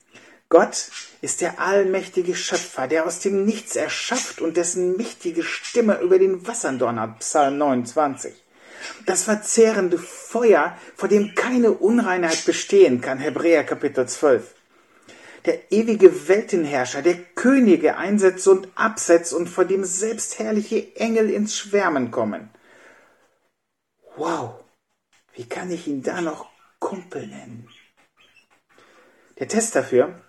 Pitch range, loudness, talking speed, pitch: 170-215 Hz, -20 LUFS, 120 wpm, 190 Hz